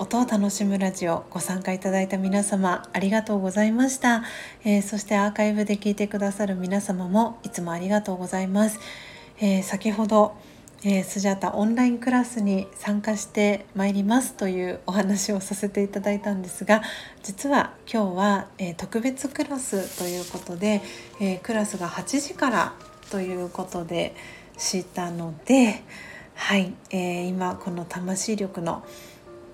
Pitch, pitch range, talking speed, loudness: 200 Hz, 185-215 Hz, 320 characters per minute, -25 LUFS